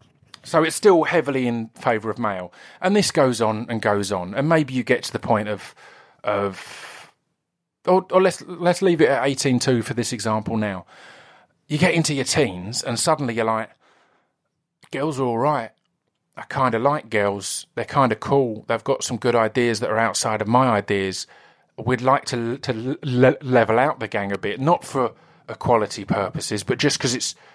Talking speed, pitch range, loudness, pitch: 195 wpm, 110-140 Hz, -21 LUFS, 120 Hz